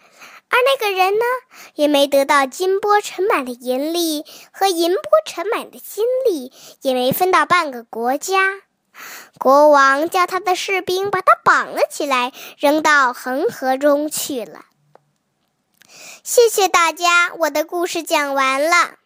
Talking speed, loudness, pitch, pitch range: 200 characters per minute, -17 LUFS, 335 Hz, 285-375 Hz